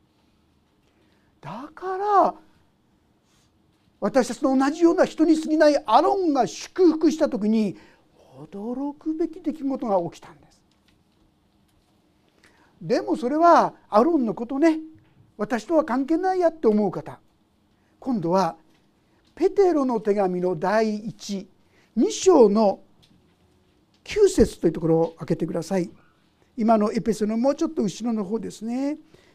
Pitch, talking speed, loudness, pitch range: 245 Hz, 235 characters per minute, -22 LUFS, 200-315 Hz